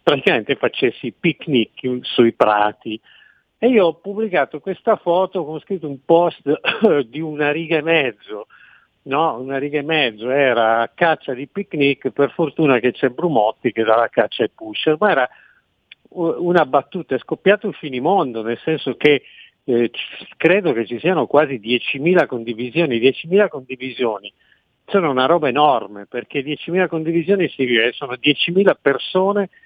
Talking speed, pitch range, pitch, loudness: 150 wpm, 125-170 Hz, 145 Hz, -18 LUFS